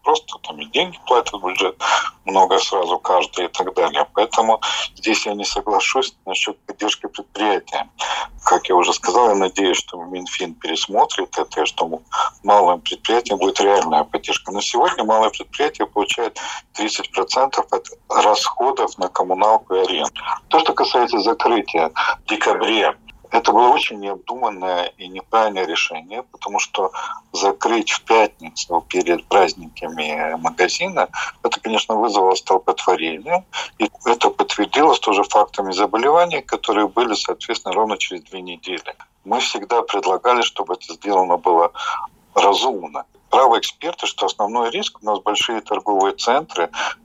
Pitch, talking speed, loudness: 175 Hz, 135 wpm, -18 LUFS